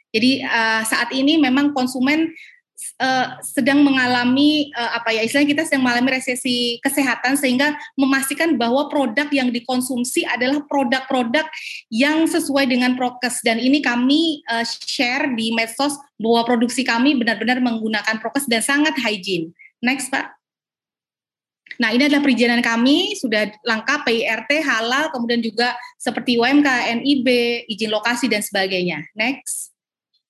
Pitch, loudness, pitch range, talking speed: 255 Hz, -18 LUFS, 235-280 Hz, 135 wpm